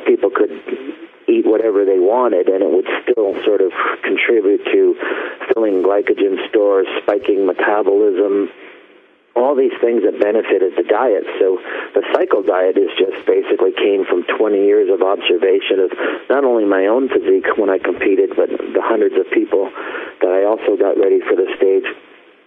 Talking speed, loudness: 165 wpm, -15 LUFS